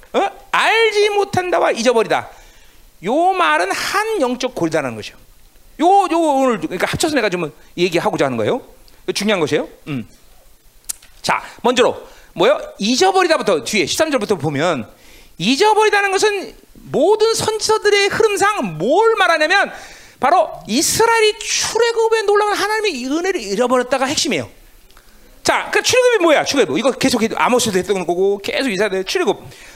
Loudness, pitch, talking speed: -16 LUFS, 340 Hz, 340 characters per minute